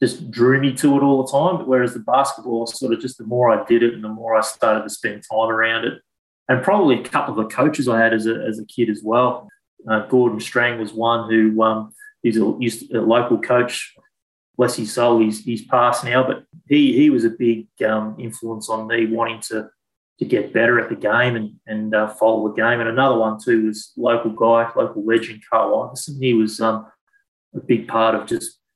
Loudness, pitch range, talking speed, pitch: -19 LUFS, 110-125 Hz, 225 wpm, 115 Hz